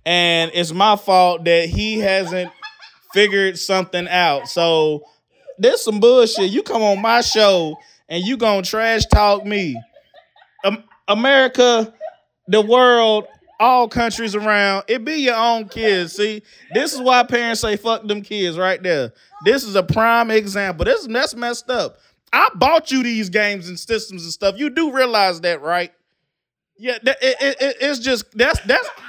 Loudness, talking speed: -17 LUFS, 160 wpm